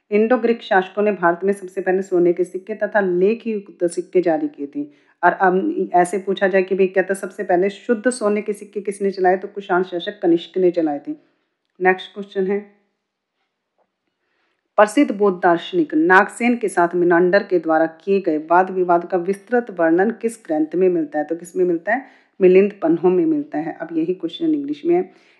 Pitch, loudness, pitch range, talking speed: 195 Hz, -19 LUFS, 180-240 Hz, 190 wpm